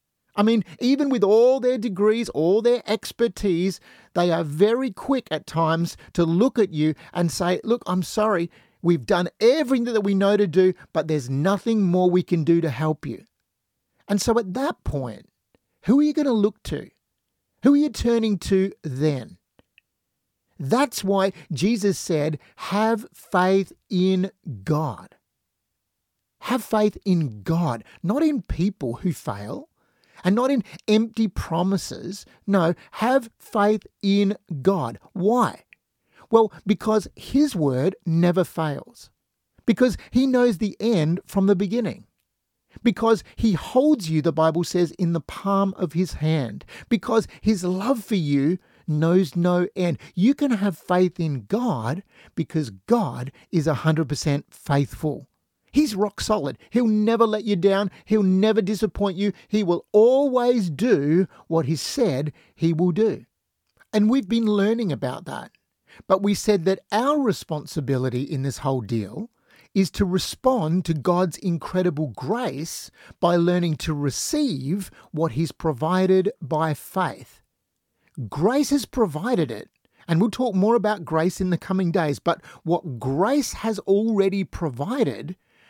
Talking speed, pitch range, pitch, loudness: 145 wpm, 165-220 Hz, 190 Hz, -22 LUFS